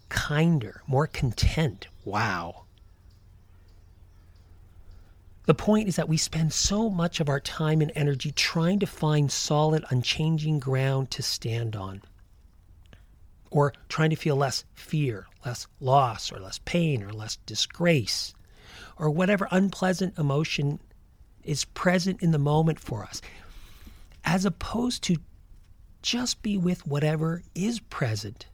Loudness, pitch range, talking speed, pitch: -27 LUFS, 95-160 Hz, 125 wpm, 135 Hz